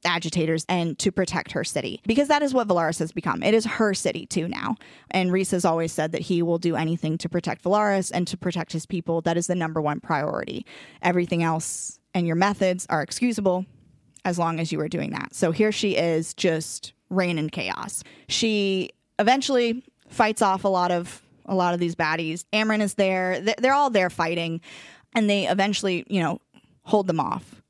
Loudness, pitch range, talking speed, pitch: -24 LUFS, 165-200 Hz, 200 wpm, 180 Hz